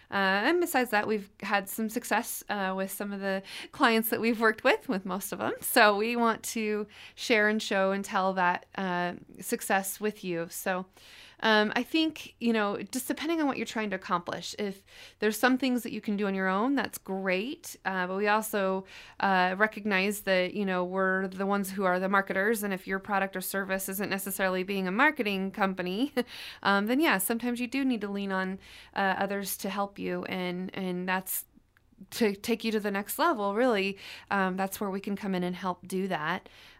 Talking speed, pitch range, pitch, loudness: 210 wpm, 190-225 Hz, 200 Hz, -29 LUFS